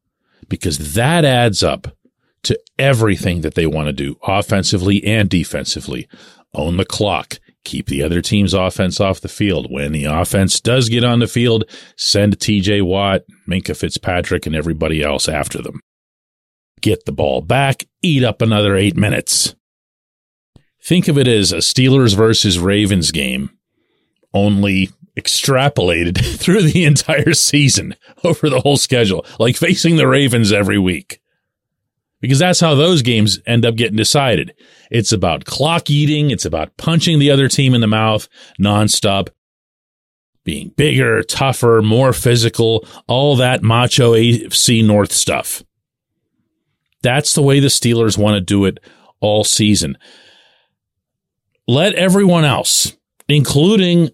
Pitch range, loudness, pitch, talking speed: 95-135 Hz, -14 LUFS, 110 Hz, 140 wpm